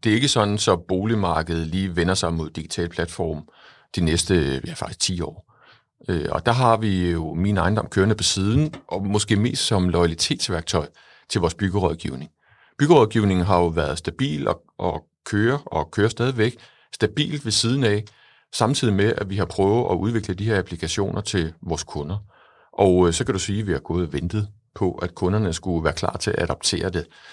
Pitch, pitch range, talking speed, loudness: 95 Hz, 85-110 Hz, 185 wpm, -22 LUFS